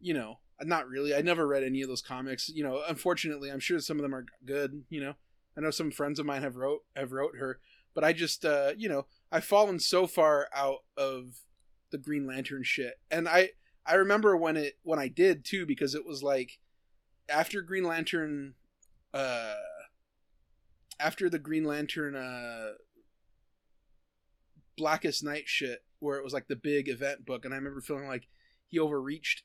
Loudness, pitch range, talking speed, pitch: -31 LUFS, 135-160 Hz, 185 wpm, 145 Hz